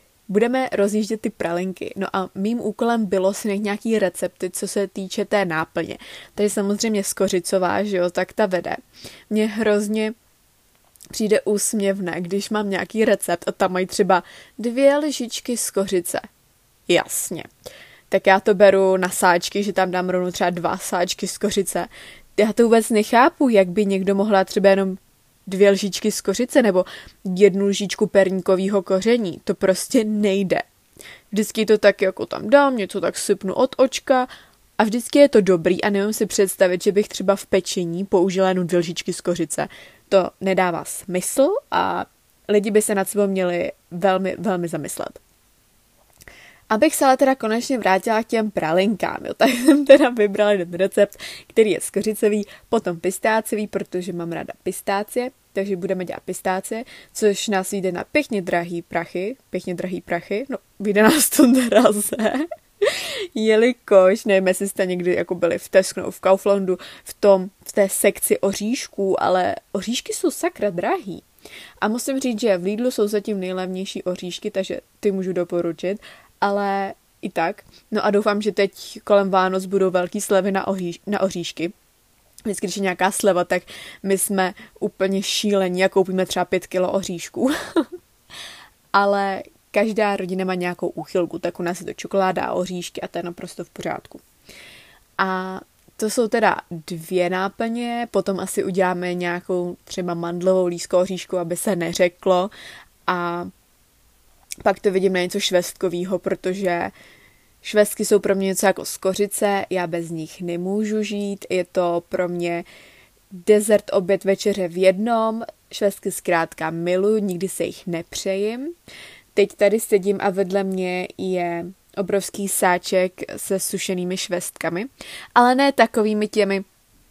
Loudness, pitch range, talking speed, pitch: -21 LUFS, 185-215 Hz, 150 wpm, 195 Hz